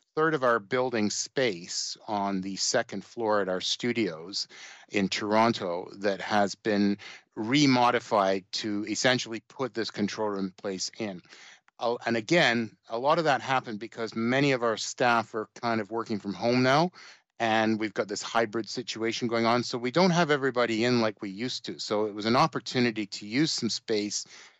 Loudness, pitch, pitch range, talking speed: -28 LUFS, 115 Hz, 105-125 Hz, 175 wpm